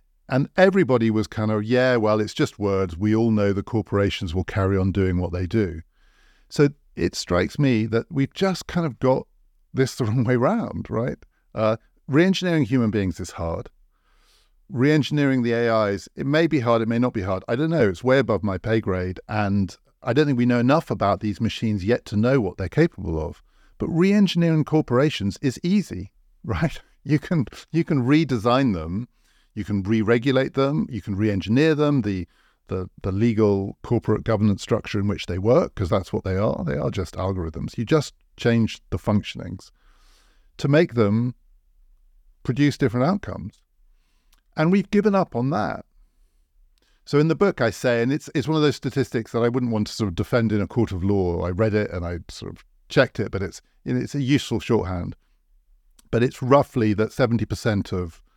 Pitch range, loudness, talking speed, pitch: 95-135 Hz, -22 LUFS, 190 wpm, 110 Hz